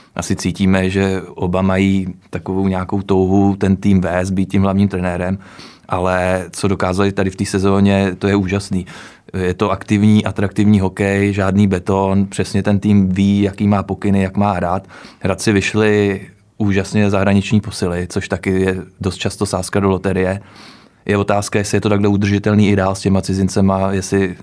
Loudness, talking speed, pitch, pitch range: -16 LUFS, 165 wpm, 100 Hz, 95-100 Hz